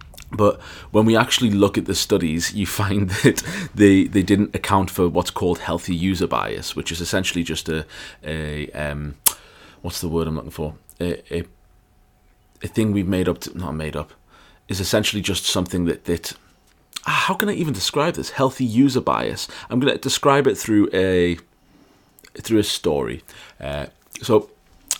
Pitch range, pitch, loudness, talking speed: 85-105 Hz, 95 Hz, -21 LUFS, 170 wpm